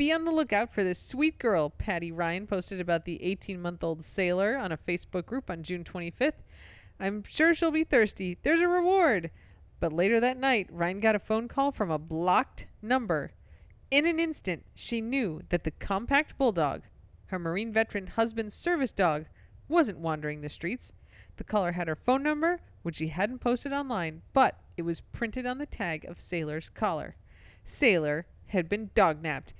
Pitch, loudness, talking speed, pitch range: 195 Hz, -29 LUFS, 180 wpm, 170-255 Hz